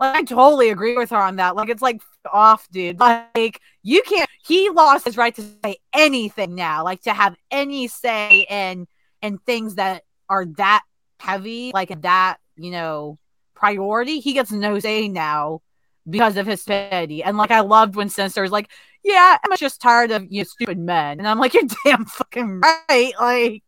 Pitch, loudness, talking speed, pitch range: 215 Hz, -17 LUFS, 190 wpm, 195-245 Hz